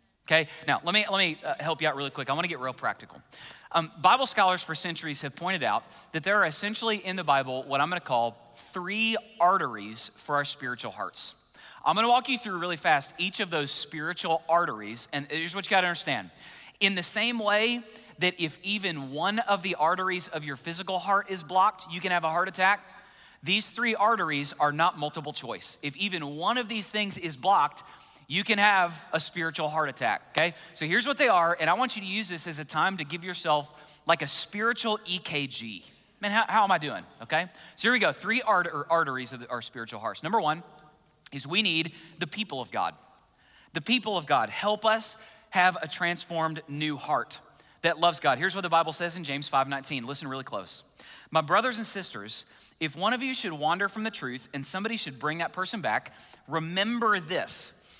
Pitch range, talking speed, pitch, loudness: 150-200 Hz, 210 wpm, 170 Hz, -28 LUFS